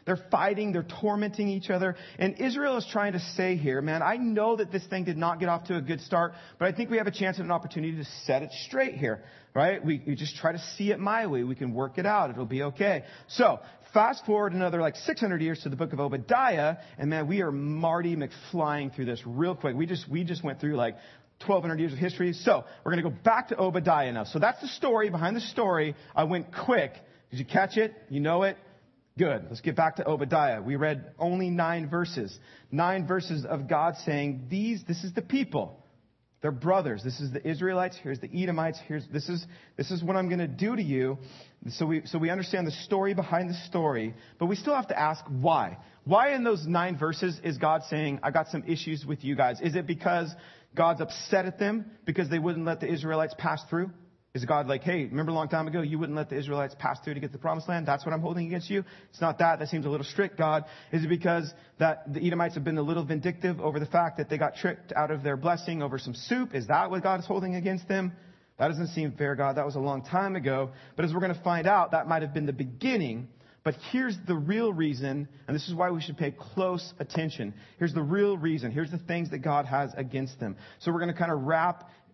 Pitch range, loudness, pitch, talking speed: 145-185 Hz, -29 LUFS, 165 Hz, 245 wpm